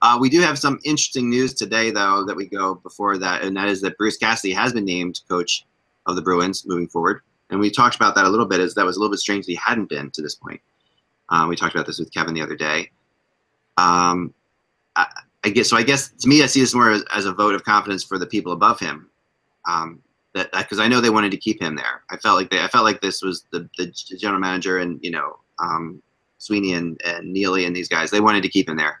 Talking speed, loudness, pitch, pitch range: 260 wpm, -19 LUFS, 95 Hz, 90-110 Hz